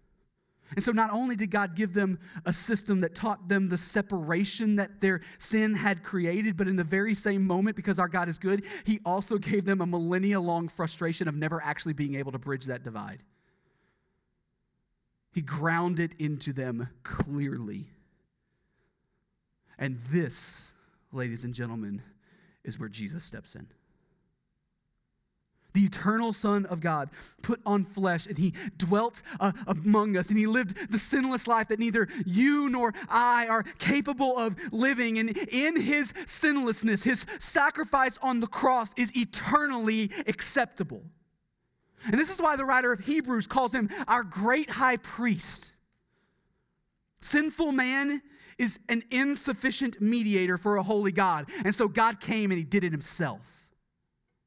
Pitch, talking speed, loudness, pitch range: 200 Hz, 150 wpm, -28 LUFS, 175-235 Hz